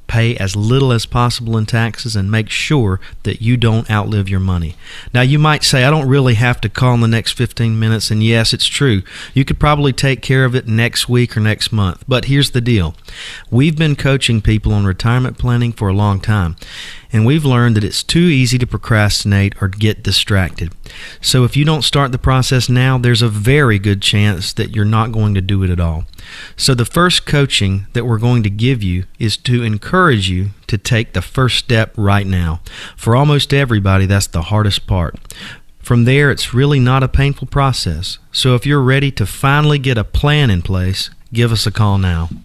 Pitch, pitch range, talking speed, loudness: 115 Hz, 100-130 Hz, 210 wpm, -14 LUFS